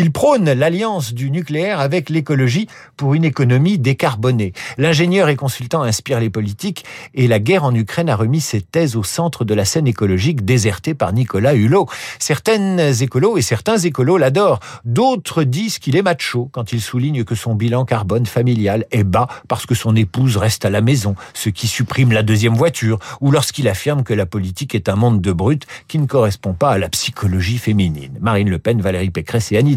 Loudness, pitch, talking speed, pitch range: -16 LUFS, 125 Hz, 195 wpm, 110-150 Hz